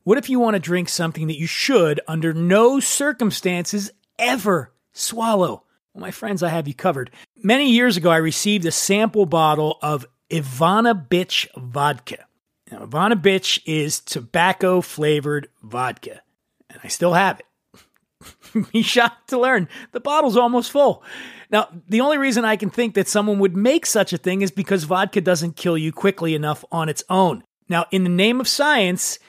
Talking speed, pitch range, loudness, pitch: 175 wpm, 165-225 Hz, -19 LUFS, 190 Hz